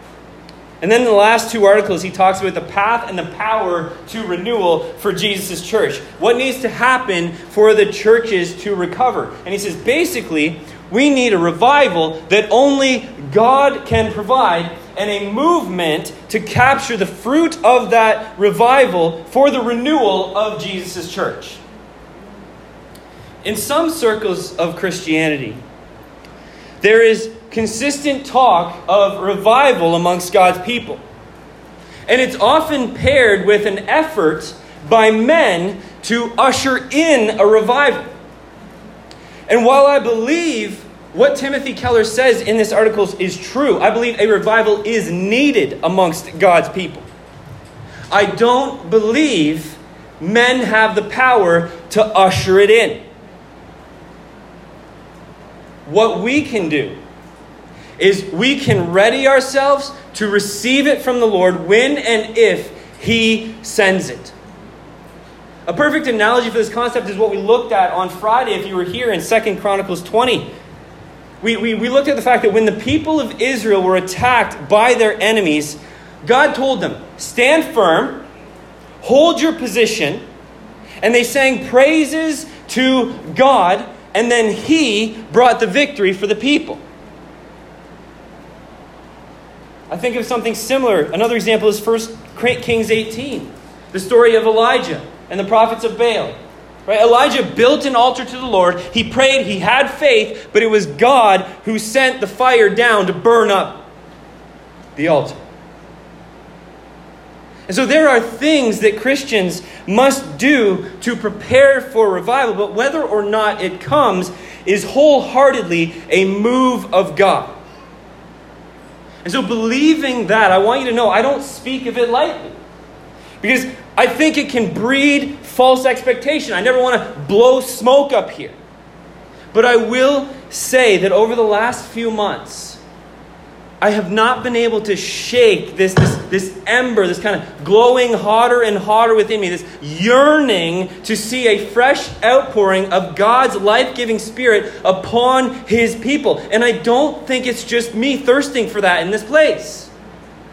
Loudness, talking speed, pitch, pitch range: -14 LUFS, 145 wpm, 225 Hz, 195-255 Hz